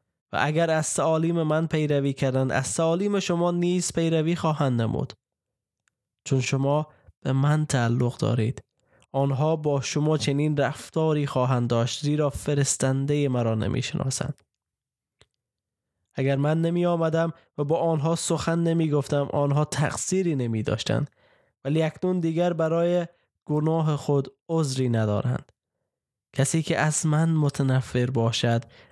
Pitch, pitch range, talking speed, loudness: 145 Hz, 130-160 Hz, 120 wpm, -25 LUFS